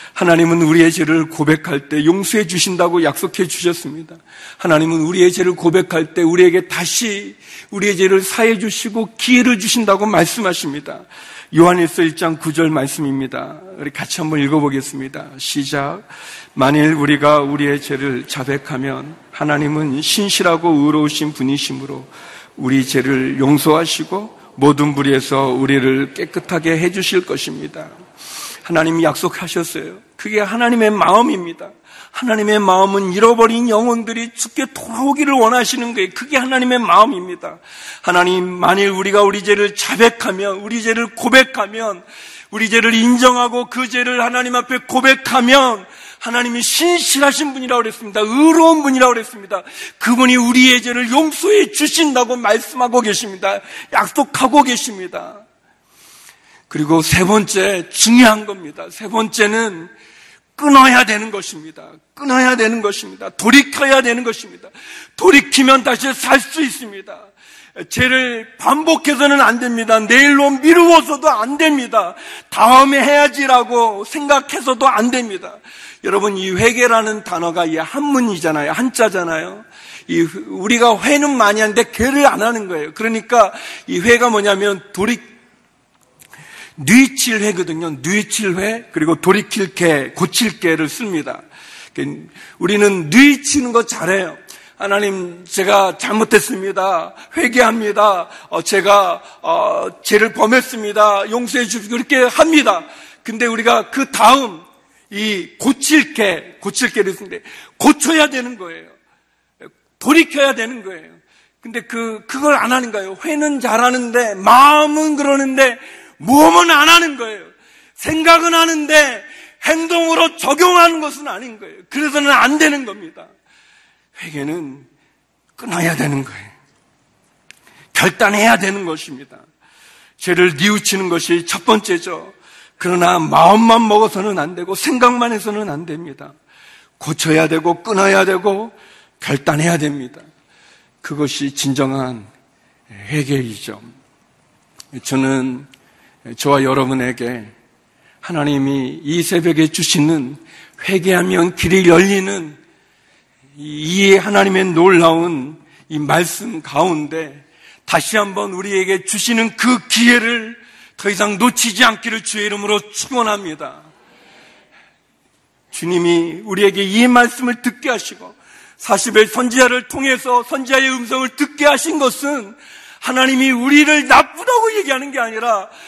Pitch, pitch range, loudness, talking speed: 210 Hz, 170-255 Hz, -13 LUFS, 295 characters per minute